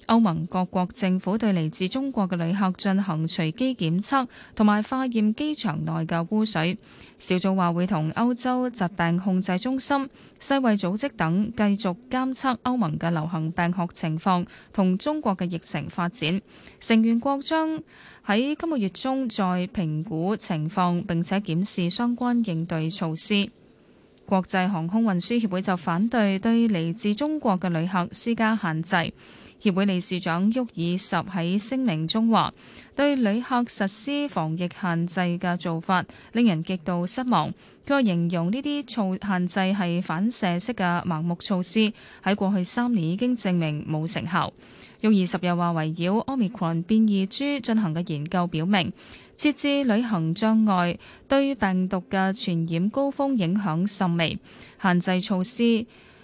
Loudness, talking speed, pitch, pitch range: -25 LUFS, 240 characters per minute, 190 Hz, 175-230 Hz